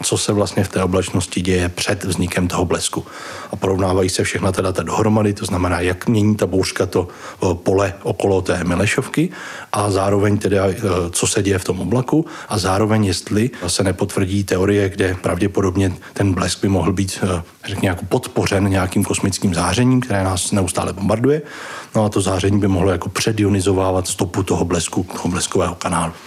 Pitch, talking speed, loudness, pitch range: 95 Hz, 170 wpm, -18 LUFS, 95-105 Hz